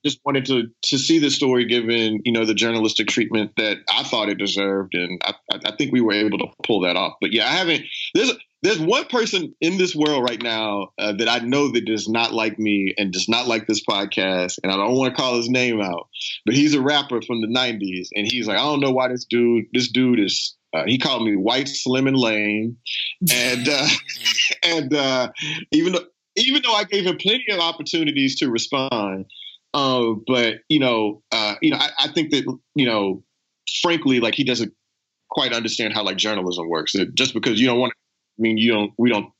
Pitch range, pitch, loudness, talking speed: 110-140 Hz, 120 Hz, -20 LUFS, 220 wpm